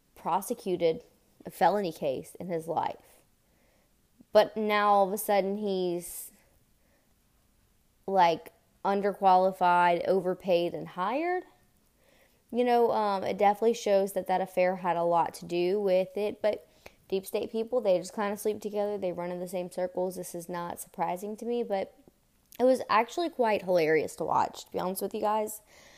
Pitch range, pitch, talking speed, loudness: 180-215 Hz, 195 Hz, 165 wpm, -29 LUFS